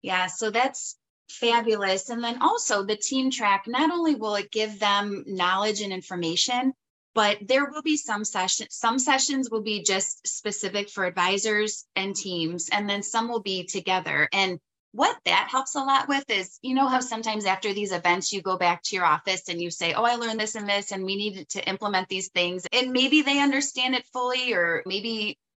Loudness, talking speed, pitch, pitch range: -25 LUFS, 200 wpm, 210 Hz, 190-245 Hz